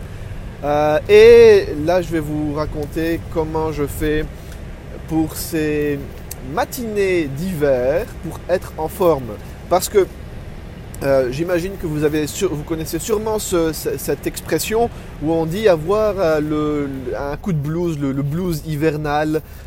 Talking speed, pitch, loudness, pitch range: 140 wpm, 155 Hz, -18 LUFS, 145-175 Hz